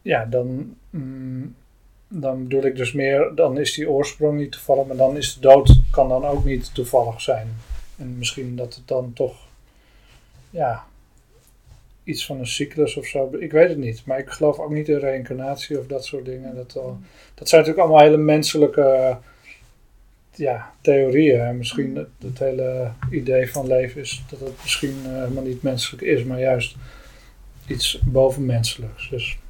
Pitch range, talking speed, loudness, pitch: 125-140 Hz, 175 wpm, -20 LUFS, 130 Hz